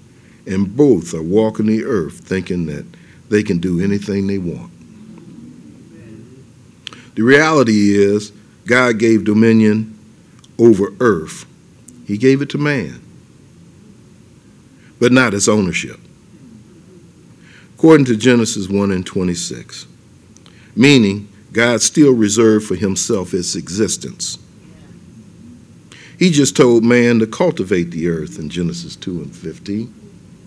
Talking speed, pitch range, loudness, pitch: 115 wpm, 100-120 Hz, -15 LUFS, 110 Hz